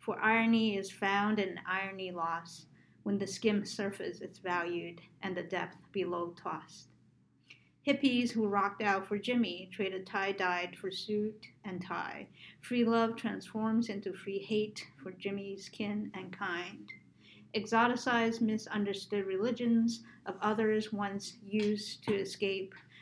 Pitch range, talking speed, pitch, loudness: 190-220 Hz, 130 wpm, 200 Hz, -34 LUFS